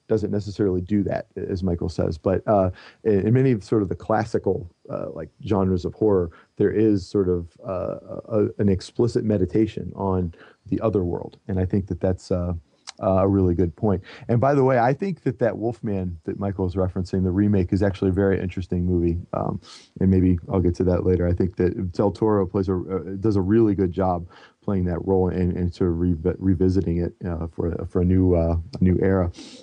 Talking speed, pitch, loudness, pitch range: 210 wpm, 95 Hz, -23 LUFS, 90-105 Hz